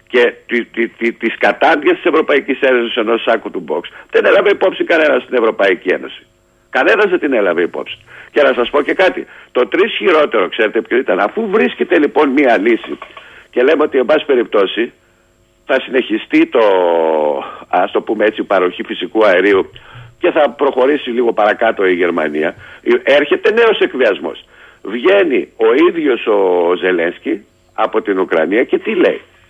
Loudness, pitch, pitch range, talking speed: -13 LUFS, 375 Hz, 330-450 Hz, 155 wpm